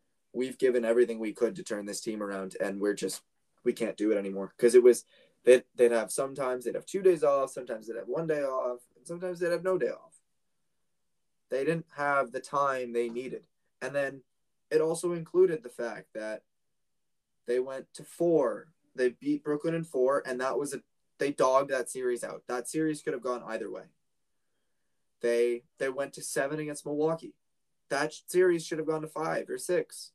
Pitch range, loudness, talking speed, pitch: 120-160 Hz, -30 LUFS, 195 wpm, 135 Hz